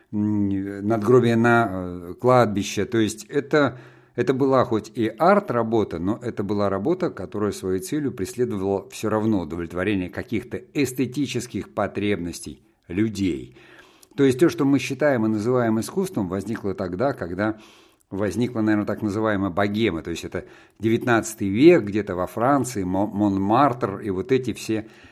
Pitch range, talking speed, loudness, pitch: 100-125 Hz, 135 wpm, -23 LUFS, 110 Hz